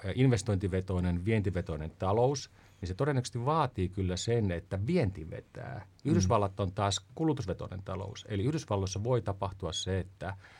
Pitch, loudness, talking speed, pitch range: 100 Hz, -32 LUFS, 130 wpm, 95-120 Hz